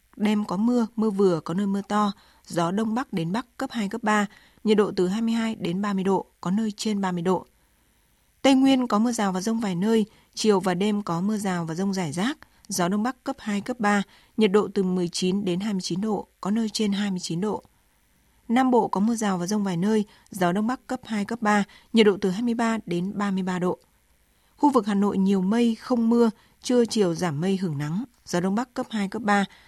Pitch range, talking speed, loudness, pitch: 190-225 Hz, 225 wpm, -25 LUFS, 205 Hz